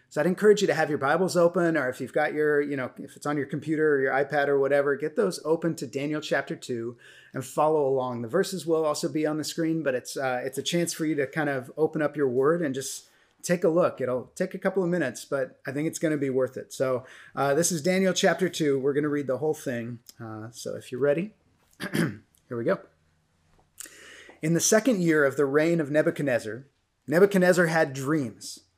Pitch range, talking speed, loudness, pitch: 130-165 Hz, 235 wpm, -26 LUFS, 150 Hz